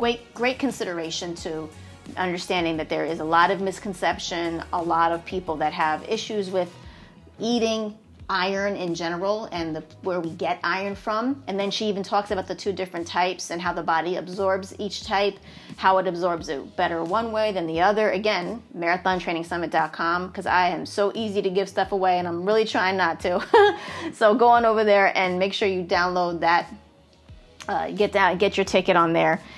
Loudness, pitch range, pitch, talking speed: -23 LUFS, 170-205 Hz, 185 Hz, 190 wpm